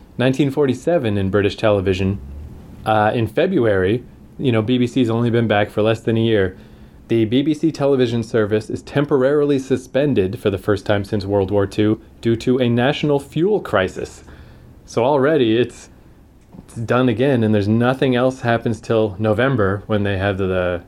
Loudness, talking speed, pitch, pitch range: -18 LUFS, 165 wpm, 115 Hz, 105-130 Hz